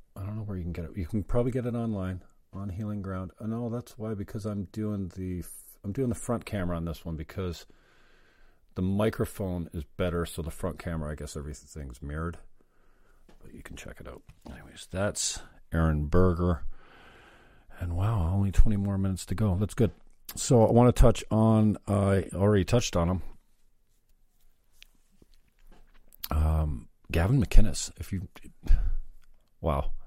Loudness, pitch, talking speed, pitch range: -29 LUFS, 95 Hz, 170 wpm, 85-105 Hz